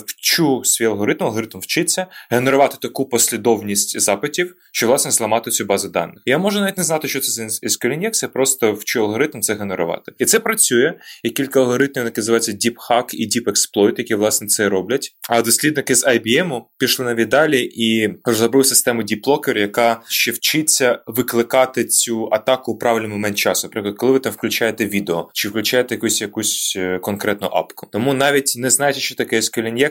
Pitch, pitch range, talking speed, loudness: 115 Hz, 110-135 Hz, 175 wpm, -17 LUFS